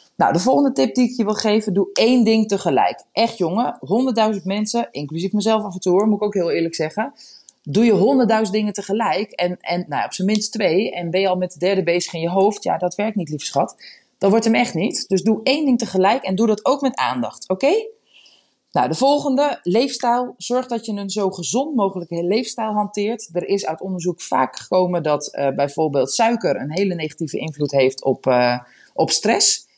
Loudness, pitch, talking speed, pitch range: -19 LUFS, 200 Hz, 215 wpm, 175-230 Hz